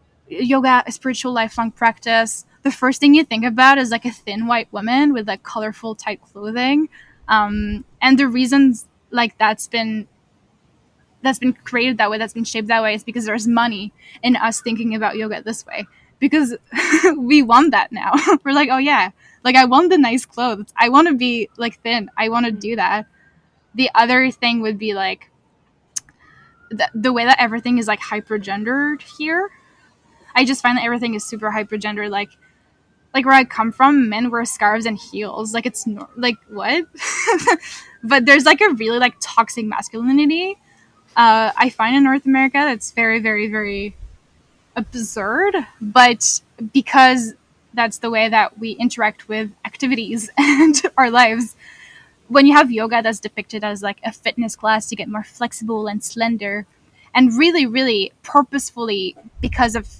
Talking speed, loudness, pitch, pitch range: 170 wpm, -16 LUFS, 235 Hz, 220-265 Hz